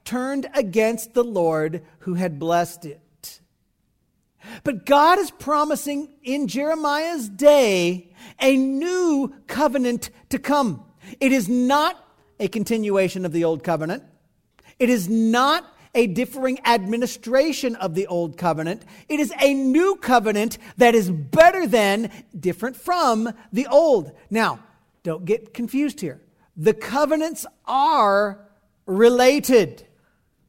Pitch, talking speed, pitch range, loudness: 235 Hz, 120 wpm, 195-275 Hz, -20 LUFS